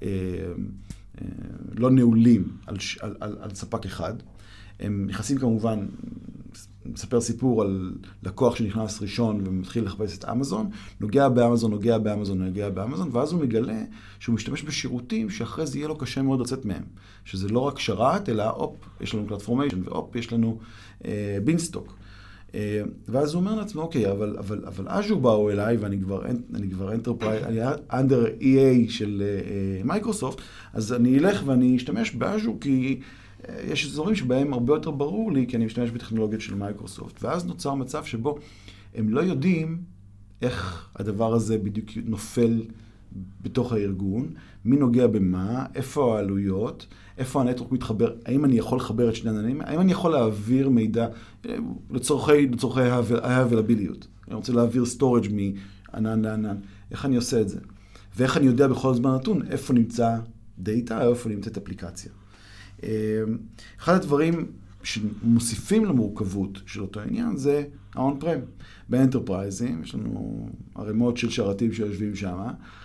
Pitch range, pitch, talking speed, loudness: 100-130 Hz, 115 Hz, 145 wpm, -25 LUFS